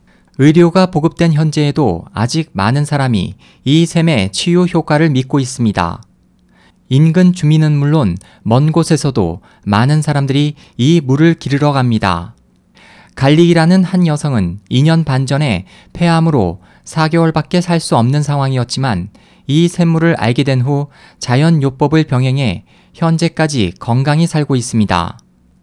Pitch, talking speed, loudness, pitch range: 145 Hz, 275 characters per minute, -13 LUFS, 115-160 Hz